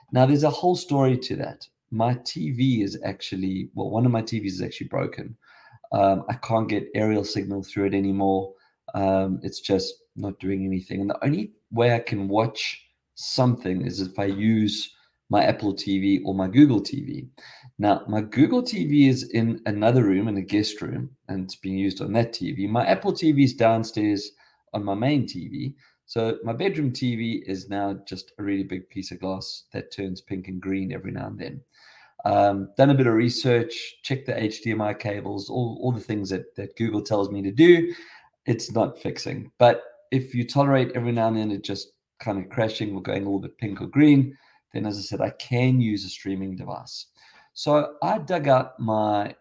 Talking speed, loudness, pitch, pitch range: 195 wpm, -24 LUFS, 110 Hz, 100-130 Hz